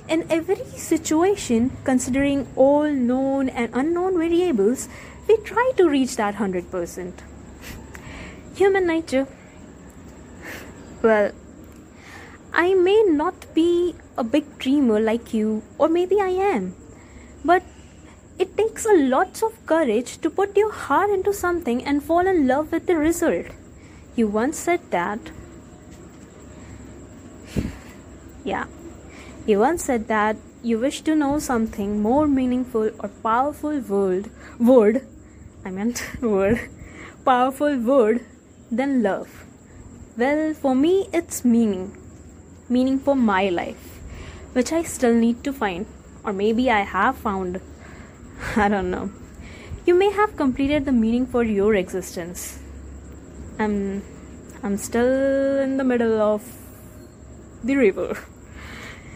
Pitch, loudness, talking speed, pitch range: 260 Hz, -21 LUFS, 120 wpm, 215-320 Hz